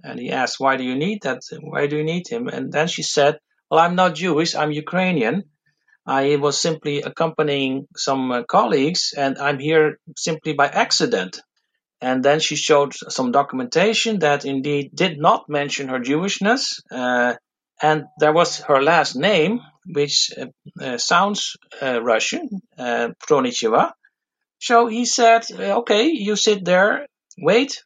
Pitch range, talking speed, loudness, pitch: 140-200 Hz, 155 wpm, -19 LUFS, 155 Hz